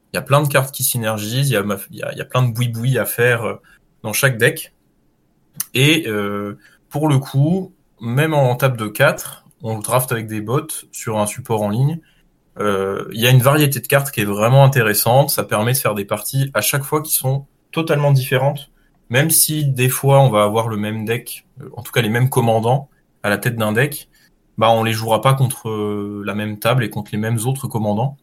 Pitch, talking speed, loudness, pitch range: 125 Hz, 220 wpm, -17 LUFS, 110-140 Hz